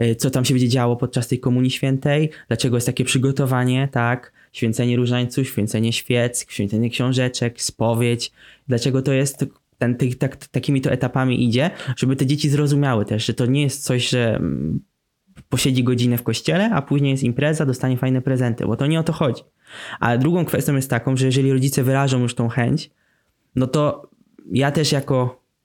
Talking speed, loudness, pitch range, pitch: 180 wpm, -20 LUFS, 120-140 Hz, 130 Hz